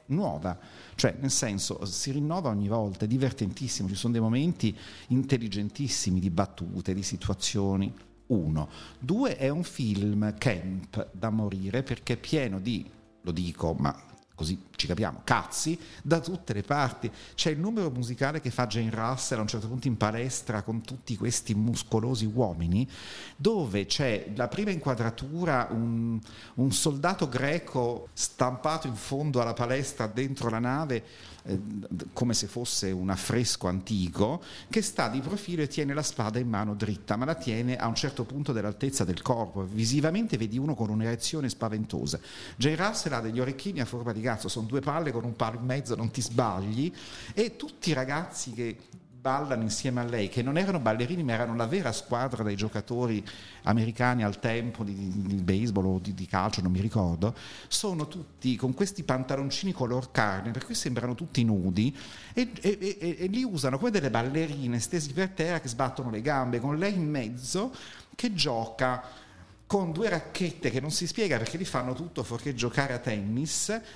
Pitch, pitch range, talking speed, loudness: 120 Hz, 105-145 Hz, 175 wpm, -30 LUFS